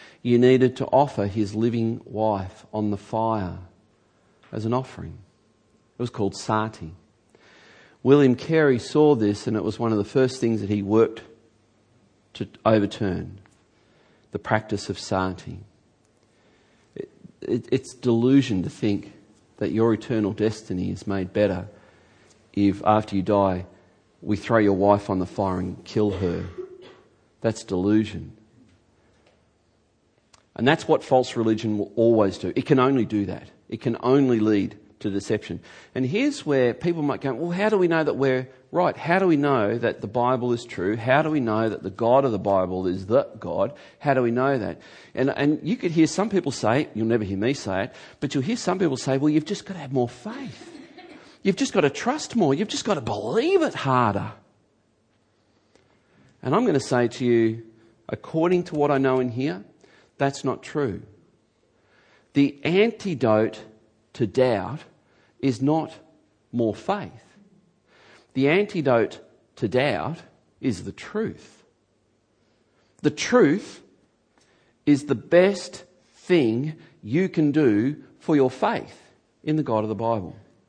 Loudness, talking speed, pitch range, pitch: -23 LUFS, 160 wpm, 105-140 Hz, 115 Hz